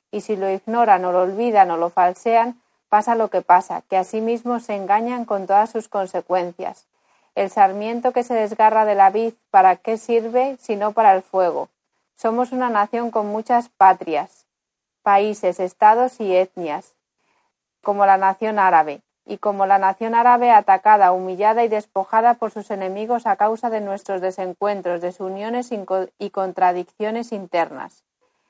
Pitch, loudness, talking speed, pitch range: 210 Hz, -19 LUFS, 160 wpm, 190-230 Hz